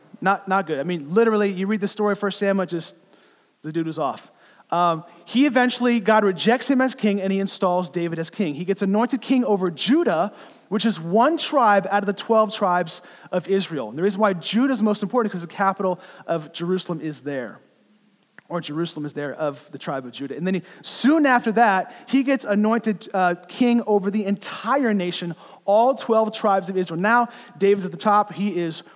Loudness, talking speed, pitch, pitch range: -22 LUFS, 210 wpm, 195 Hz, 175-220 Hz